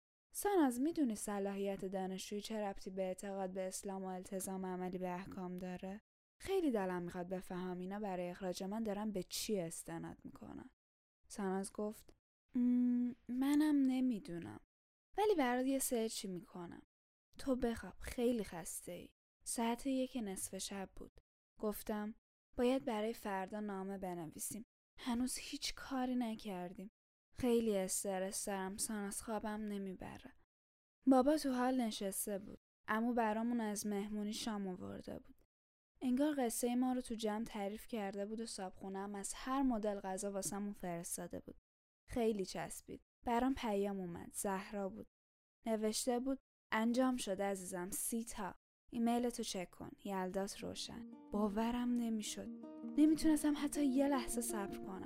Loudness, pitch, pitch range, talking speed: -40 LUFS, 215 Hz, 190-245 Hz, 135 wpm